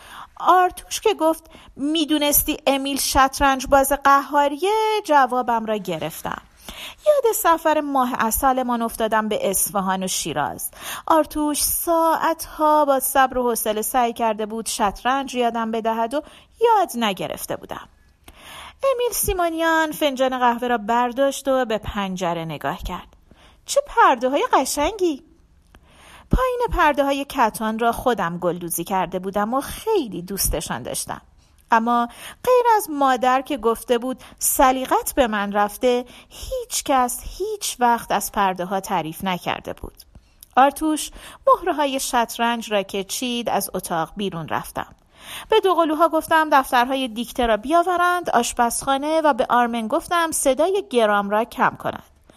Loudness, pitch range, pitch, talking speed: -20 LUFS, 225-310 Hz, 265 Hz, 130 wpm